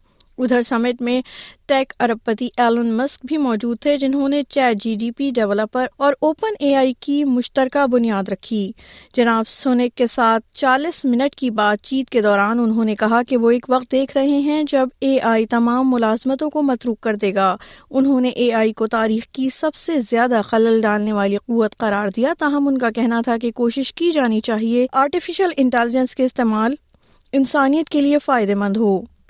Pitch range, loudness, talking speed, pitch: 225-270 Hz, -18 LUFS, 190 wpm, 245 Hz